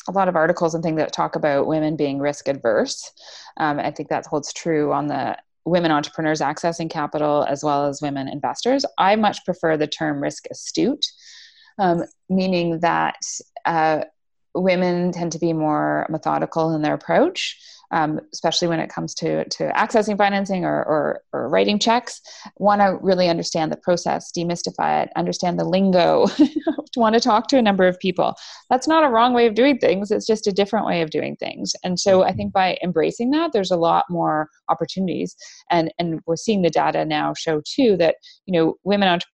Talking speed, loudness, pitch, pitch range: 190 wpm, -20 LUFS, 180 Hz, 160-210 Hz